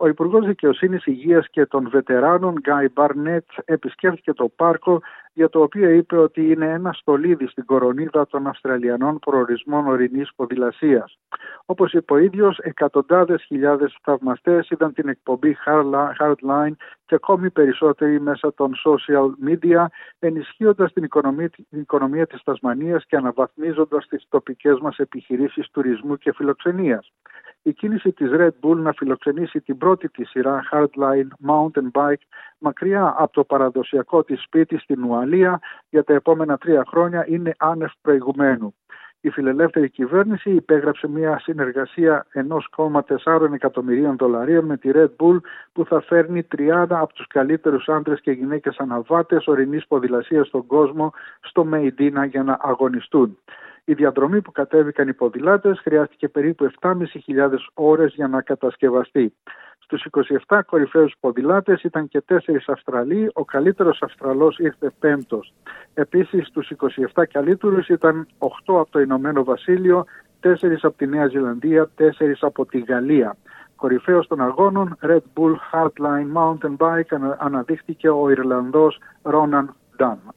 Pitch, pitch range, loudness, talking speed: 150 Hz, 140-165 Hz, -19 LUFS, 135 wpm